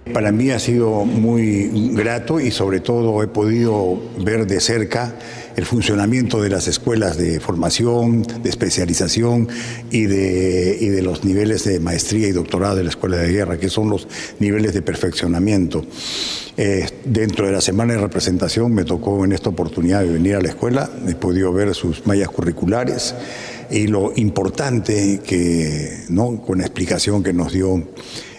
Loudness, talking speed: -18 LUFS, 165 wpm